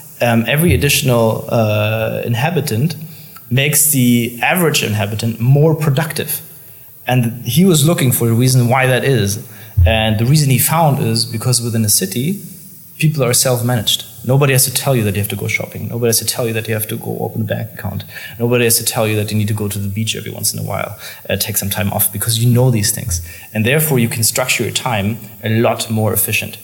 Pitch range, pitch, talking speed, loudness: 110-135 Hz, 120 Hz, 220 wpm, -15 LUFS